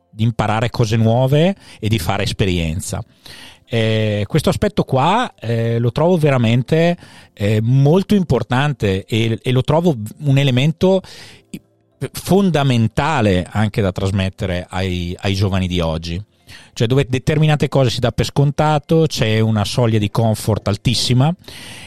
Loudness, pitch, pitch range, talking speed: -17 LUFS, 120 Hz, 105-145 Hz, 130 wpm